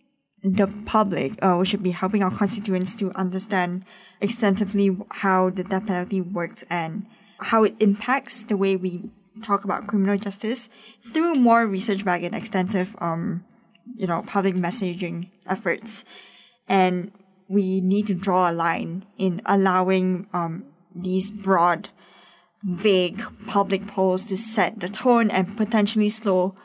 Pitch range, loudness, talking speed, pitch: 185-210 Hz, -23 LUFS, 140 wpm, 195 Hz